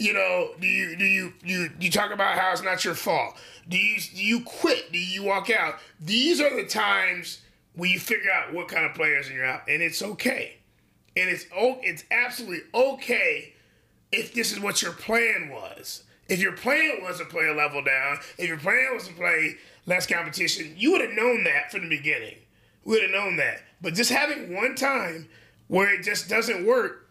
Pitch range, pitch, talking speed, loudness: 175-235 Hz, 195 Hz, 210 wpm, -24 LUFS